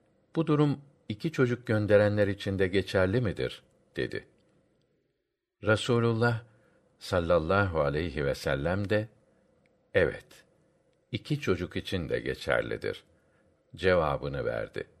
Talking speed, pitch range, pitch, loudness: 95 wpm, 105-150 Hz, 115 Hz, -29 LUFS